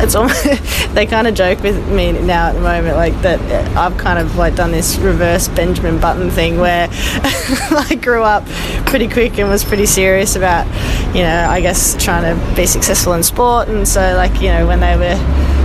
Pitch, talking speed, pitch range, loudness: 205 Hz, 205 wpm, 185-235 Hz, -13 LUFS